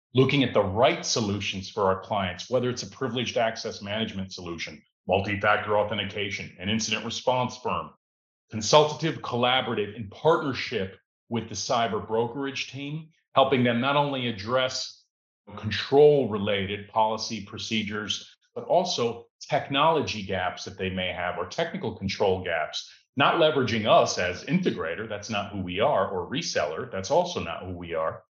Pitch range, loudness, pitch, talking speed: 100-130 Hz, -26 LUFS, 110 Hz, 145 wpm